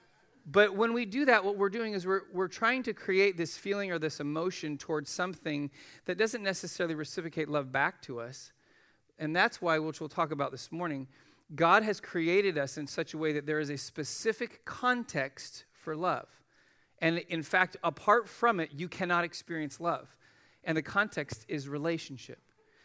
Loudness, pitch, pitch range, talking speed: -32 LUFS, 170 Hz, 150-200 Hz, 180 wpm